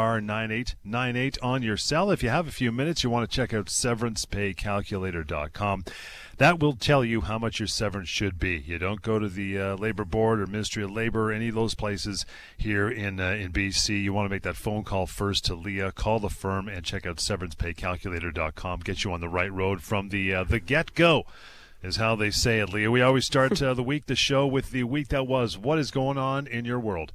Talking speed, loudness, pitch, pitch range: 235 wpm, -27 LUFS, 105 Hz, 95-125 Hz